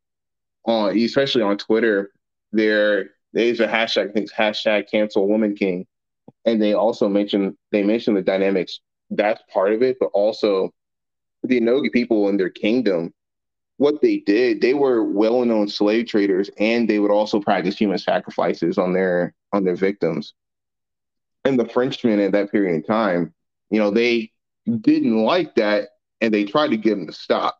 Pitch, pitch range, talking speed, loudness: 105 Hz, 100-120 Hz, 170 wpm, -20 LUFS